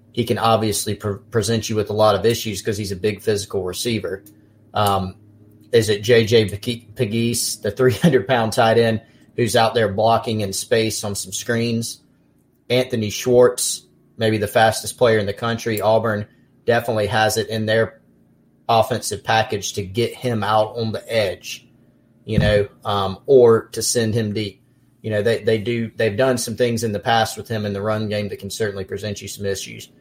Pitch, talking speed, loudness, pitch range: 110 Hz, 185 wpm, -20 LUFS, 105-115 Hz